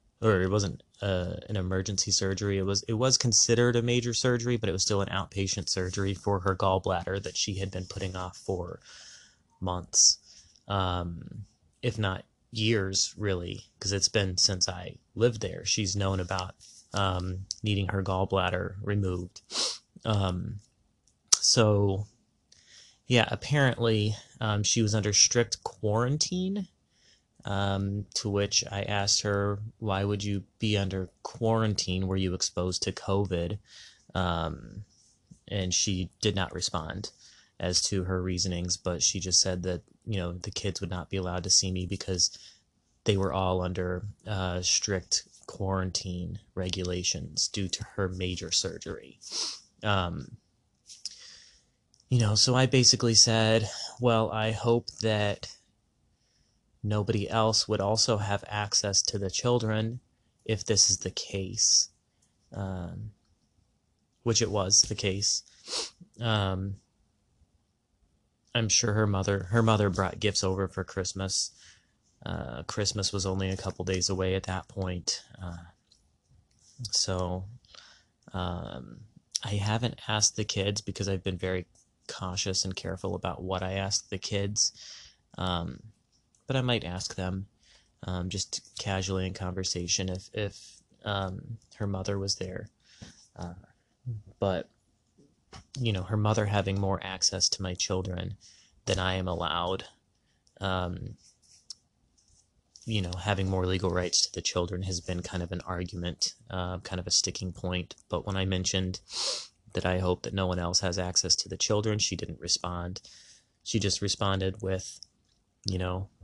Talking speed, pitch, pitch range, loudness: 140 wpm, 95 Hz, 90-110 Hz, -28 LUFS